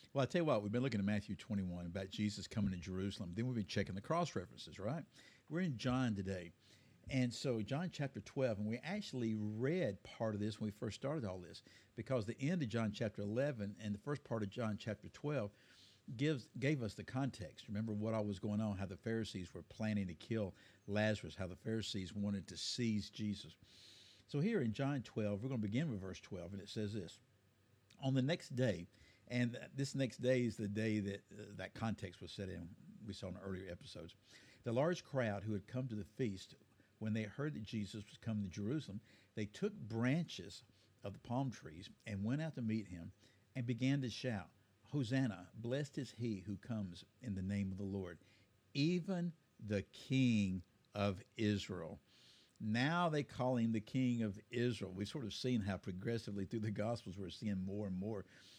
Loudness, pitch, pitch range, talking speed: -42 LUFS, 105 Hz, 100-125 Hz, 205 wpm